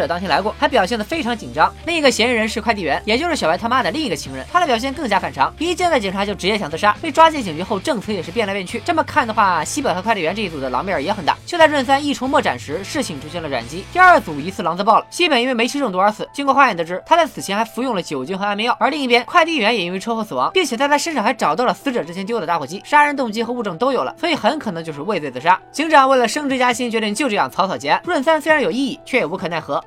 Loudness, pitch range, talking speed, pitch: -18 LUFS, 210-295 Hz, 455 characters per minute, 245 Hz